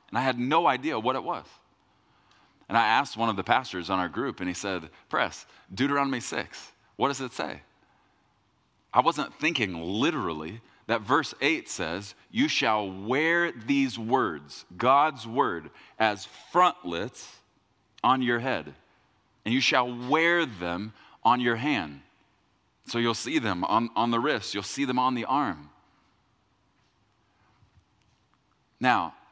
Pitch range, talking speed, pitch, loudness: 100-130 Hz, 145 wpm, 115 Hz, -27 LUFS